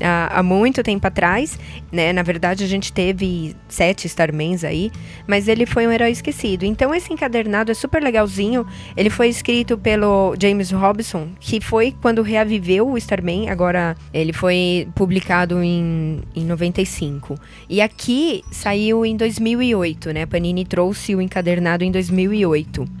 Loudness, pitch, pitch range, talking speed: -18 LUFS, 190 Hz, 175-225 Hz, 145 wpm